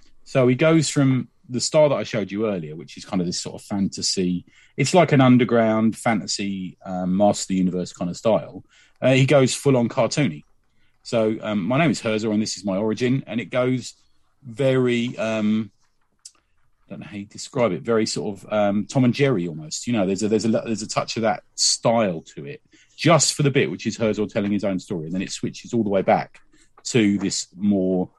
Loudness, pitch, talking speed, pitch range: -21 LUFS, 110 Hz, 225 wpm, 100-125 Hz